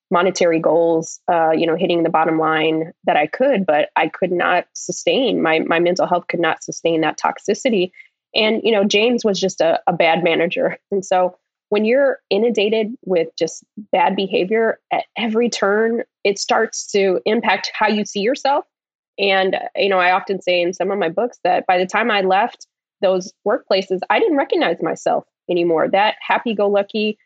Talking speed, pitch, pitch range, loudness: 180 wpm, 190 Hz, 175-215 Hz, -18 LUFS